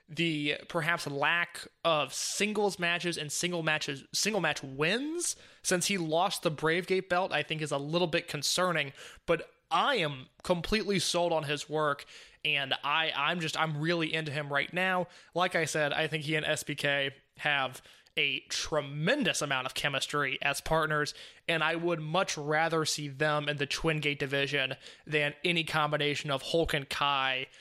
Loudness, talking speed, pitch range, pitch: -30 LUFS, 170 wpm, 145-175 Hz, 155 Hz